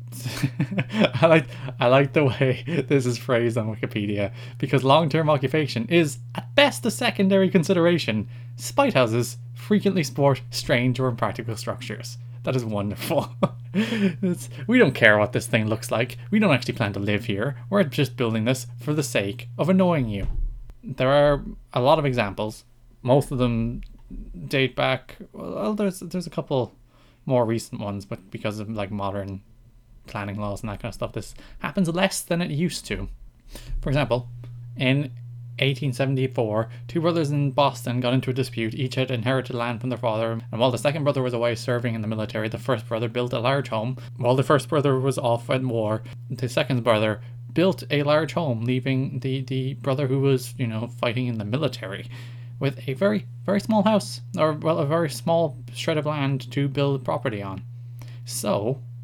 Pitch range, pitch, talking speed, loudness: 120-145 Hz, 125 Hz, 180 wpm, -24 LUFS